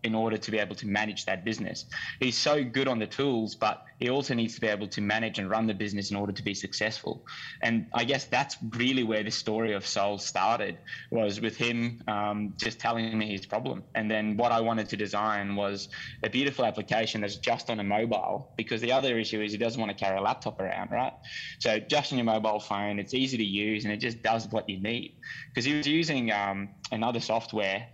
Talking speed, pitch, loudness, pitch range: 230 wpm, 110 Hz, -29 LUFS, 105-115 Hz